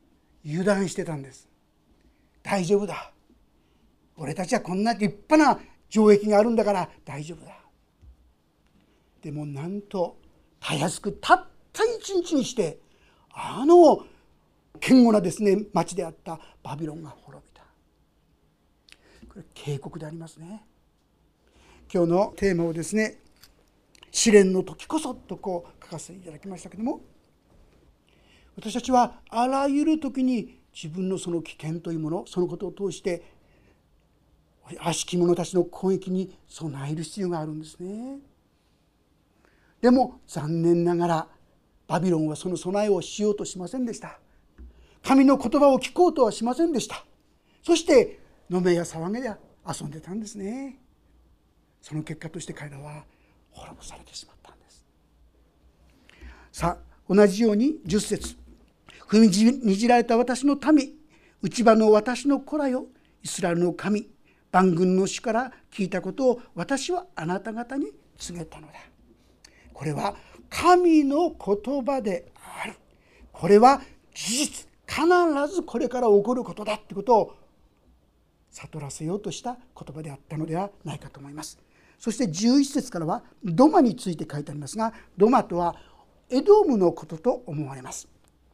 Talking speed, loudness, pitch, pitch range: 275 characters per minute, -24 LUFS, 195 Hz, 165-245 Hz